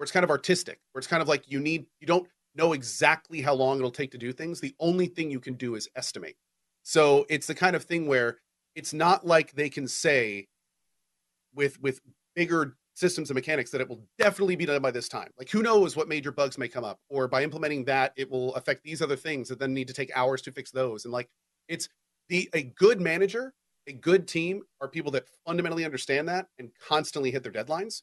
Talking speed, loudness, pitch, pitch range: 230 wpm, -28 LUFS, 145 Hz, 130-165 Hz